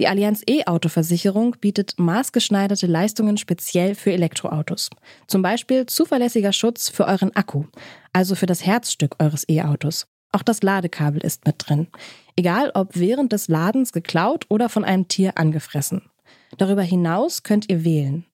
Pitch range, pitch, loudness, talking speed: 165-210 Hz, 190 Hz, -20 LUFS, 145 wpm